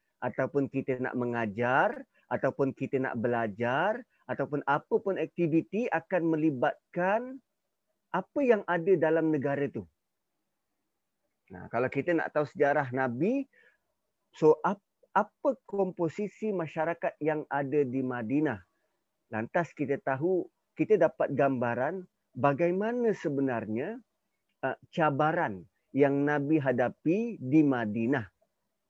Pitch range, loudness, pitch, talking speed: 130-185 Hz, -30 LUFS, 150 Hz, 105 wpm